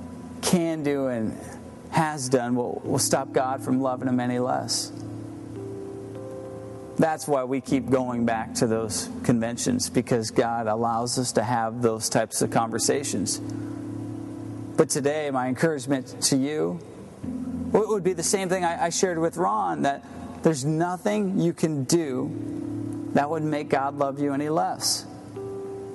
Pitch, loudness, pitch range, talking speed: 135 Hz, -25 LUFS, 120-165 Hz, 150 wpm